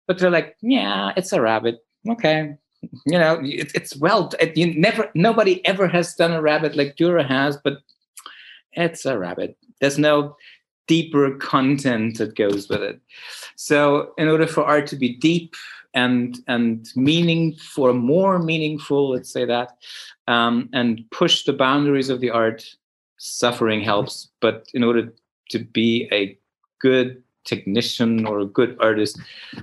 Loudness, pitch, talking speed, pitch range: -20 LUFS, 140 Hz, 150 wpm, 120-165 Hz